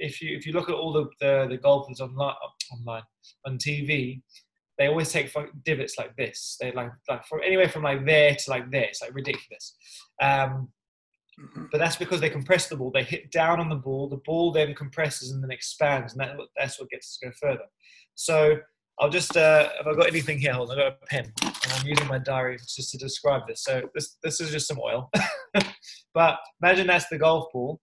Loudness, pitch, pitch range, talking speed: -25 LUFS, 150 Hz, 135-165 Hz, 220 wpm